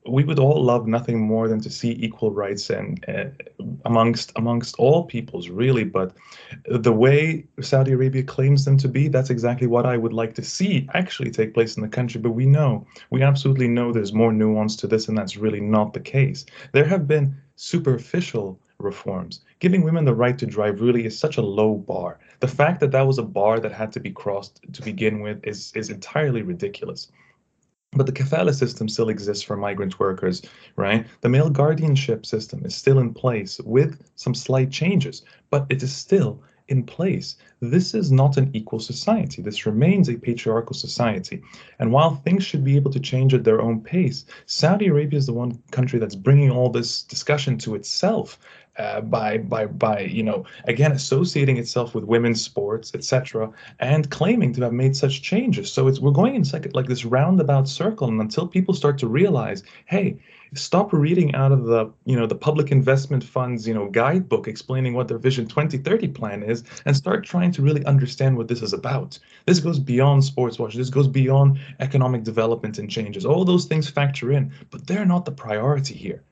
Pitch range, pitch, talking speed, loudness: 115-145 Hz, 130 Hz, 195 wpm, -21 LUFS